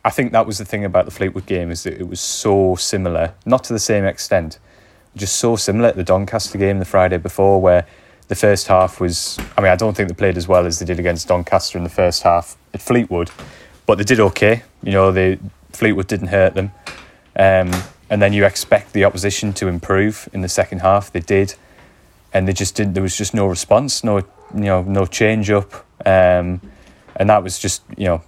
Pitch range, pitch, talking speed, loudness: 90-105 Hz, 95 Hz, 220 wpm, -17 LUFS